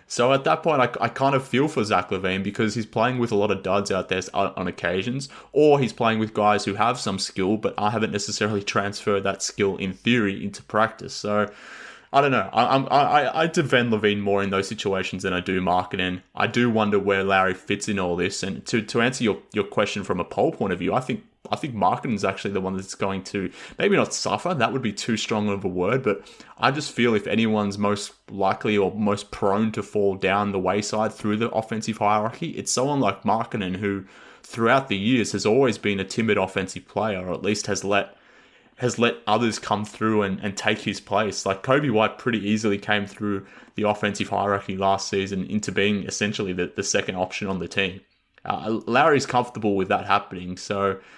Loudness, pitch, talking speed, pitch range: -23 LUFS, 105 Hz, 215 wpm, 100-110 Hz